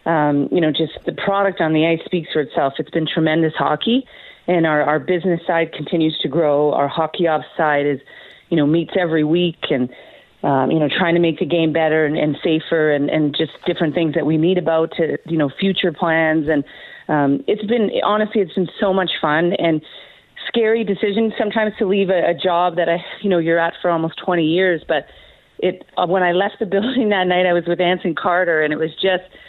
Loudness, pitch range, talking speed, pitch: -18 LUFS, 155-185 Hz, 220 wpm, 170 Hz